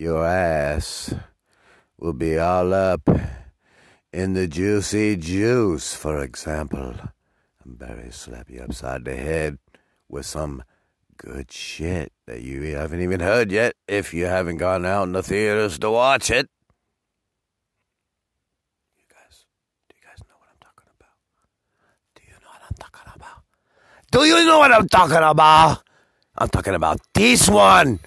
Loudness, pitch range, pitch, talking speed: -18 LUFS, 75-105 Hz, 90 Hz, 145 wpm